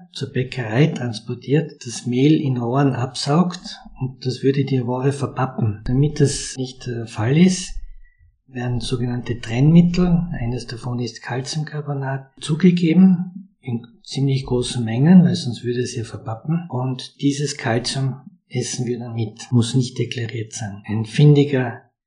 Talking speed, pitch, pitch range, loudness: 140 wpm, 130 Hz, 120-150 Hz, -20 LUFS